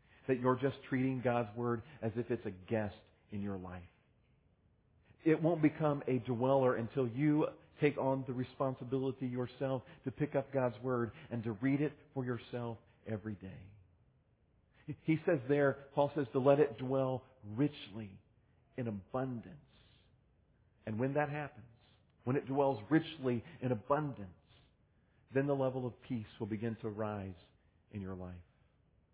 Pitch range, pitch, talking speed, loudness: 110-135 Hz, 125 Hz, 150 wpm, -36 LUFS